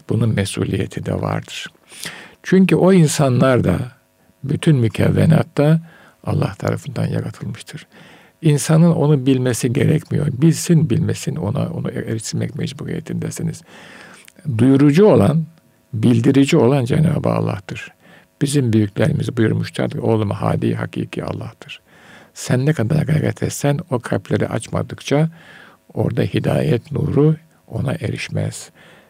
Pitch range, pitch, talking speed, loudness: 125-160 Hz, 150 Hz, 105 wpm, -18 LUFS